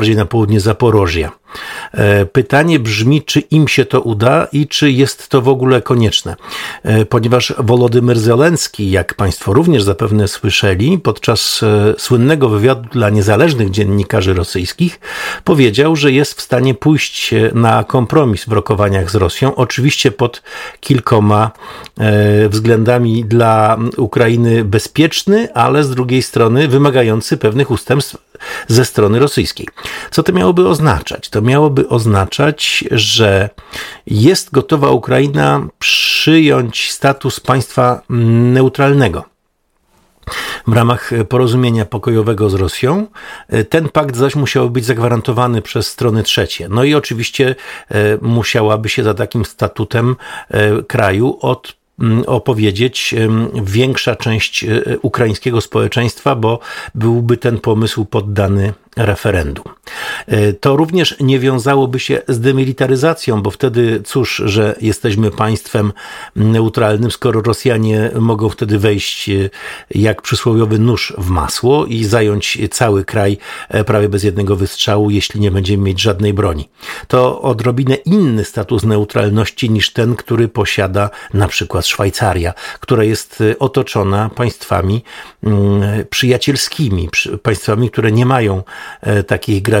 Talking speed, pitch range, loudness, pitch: 115 wpm, 105-130 Hz, -13 LUFS, 115 Hz